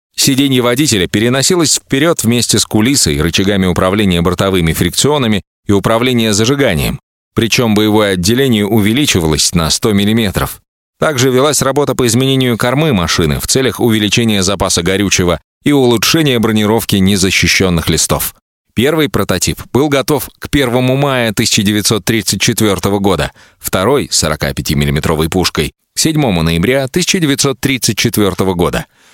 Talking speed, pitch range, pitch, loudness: 115 wpm, 95-130 Hz, 110 Hz, -12 LUFS